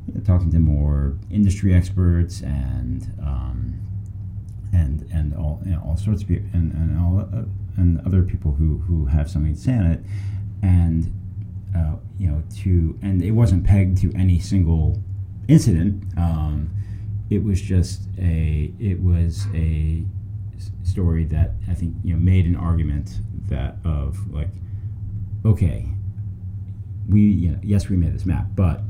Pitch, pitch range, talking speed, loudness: 95 Hz, 85-100 Hz, 150 wpm, -21 LUFS